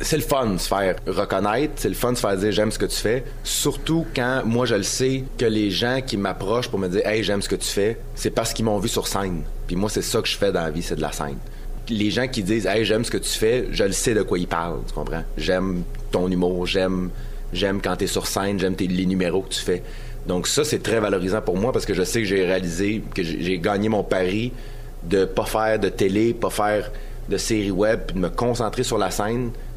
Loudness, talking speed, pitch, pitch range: -23 LUFS, 265 wpm, 105 Hz, 95-115 Hz